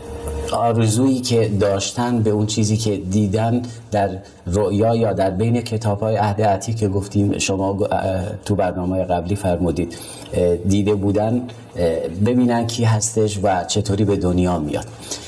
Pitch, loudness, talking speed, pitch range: 105 Hz, -19 LUFS, 125 wpm, 95-115 Hz